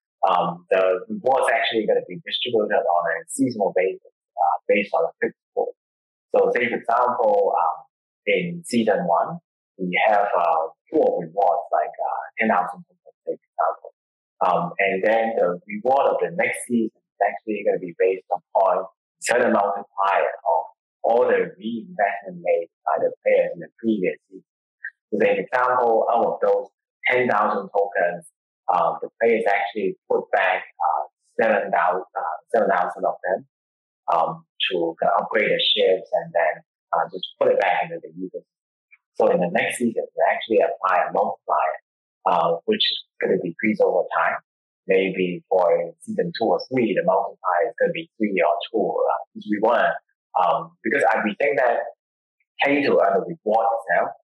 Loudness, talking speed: -22 LUFS, 170 wpm